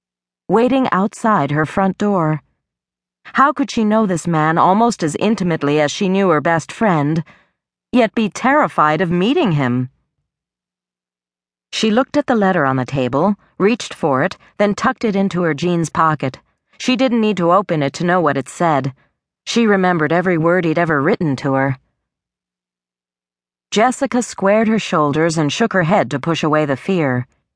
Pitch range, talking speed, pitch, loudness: 135-205 Hz, 170 wpm, 170 Hz, -16 LUFS